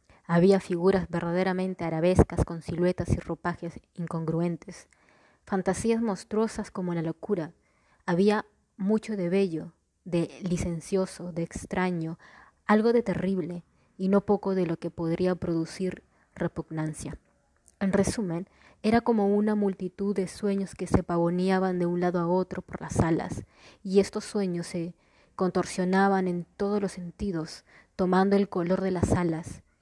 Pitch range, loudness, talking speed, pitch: 170-195 Hz, -28 LUFS, 135 wpm, 185 Hz